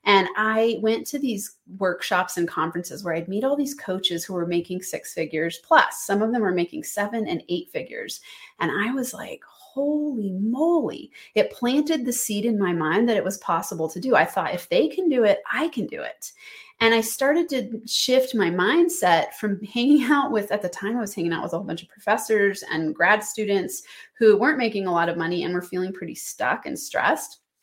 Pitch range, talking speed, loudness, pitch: 180-255 Hz, 215 wpm, -23 LUFS, 210 Hz